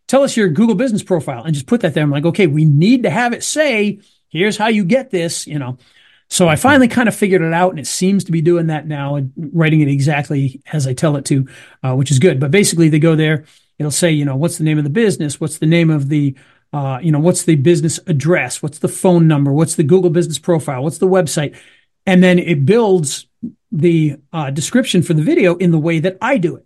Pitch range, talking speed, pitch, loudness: 150-185 Hz, 250 wpm, 165 Hz, -14 LUFS